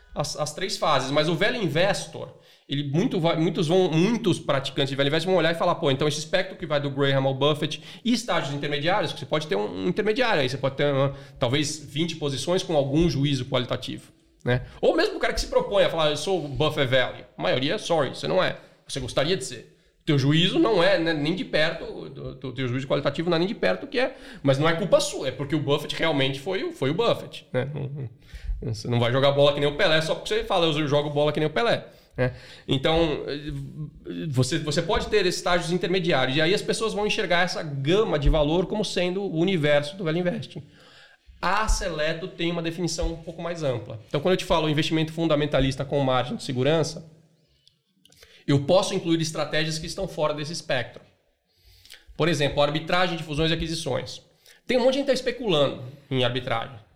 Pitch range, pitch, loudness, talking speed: 140-180 Hz, 155 Hz, -24 LUFS, 215 wpm